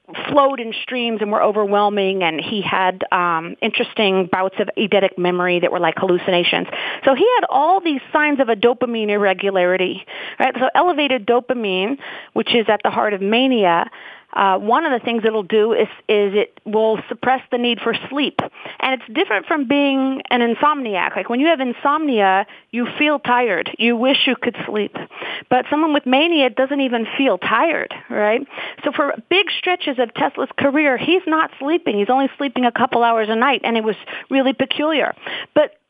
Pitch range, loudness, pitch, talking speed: 210-280 Hz, -18 LUFS, 245 Hz, 180 wpm